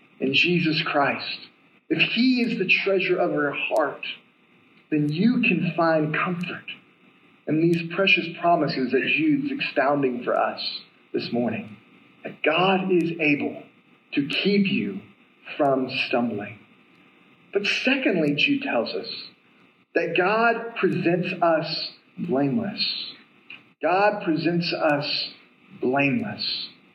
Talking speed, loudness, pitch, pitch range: 110 wpm, -23 LUFS, 170 Hz, 145-200 Hz